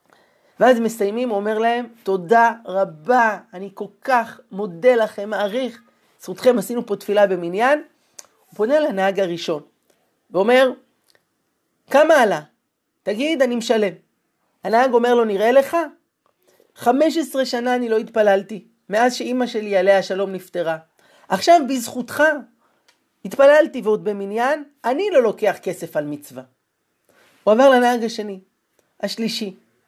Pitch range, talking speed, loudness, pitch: 200-255 Hz, 120 wpm, -19 LUFS, 225 Hz